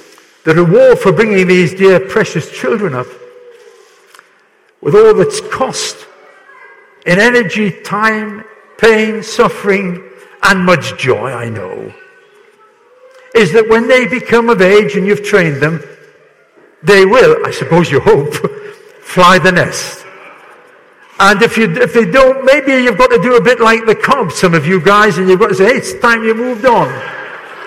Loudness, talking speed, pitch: -10 LUFS, 155 wpm, 235 Hz